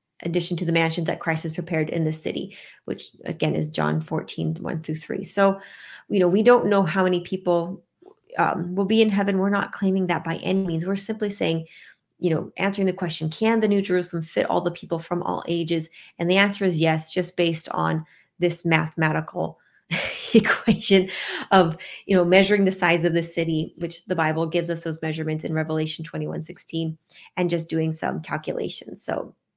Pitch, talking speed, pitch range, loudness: 175 Hz, 190 wpm, 160-190 Hz, -23 LUFS